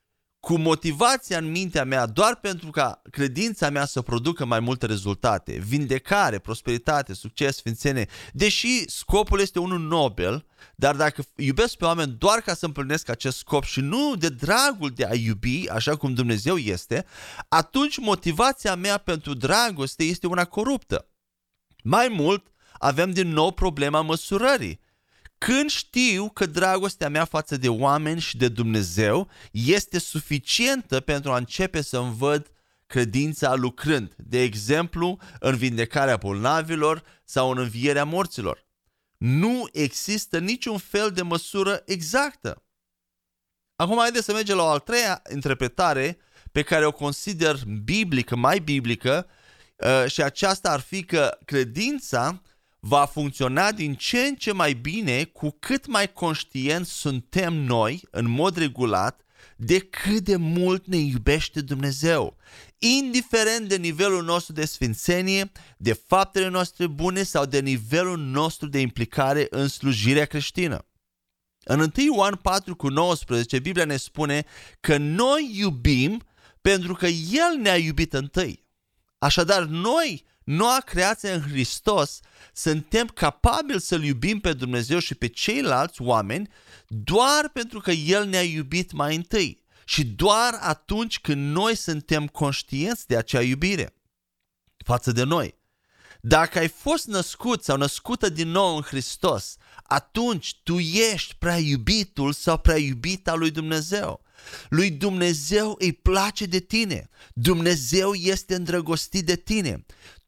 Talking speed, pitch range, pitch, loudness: 135 wpm, 135-190 Hz, 160 Hz, -23 LUFS